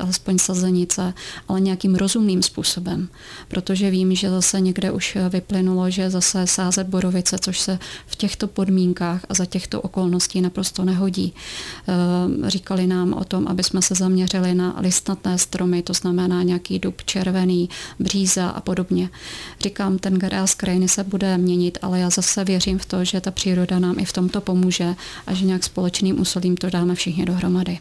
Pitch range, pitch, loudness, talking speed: 180-190 Hz, 185 Hz, -20 LUFS, 170 wpm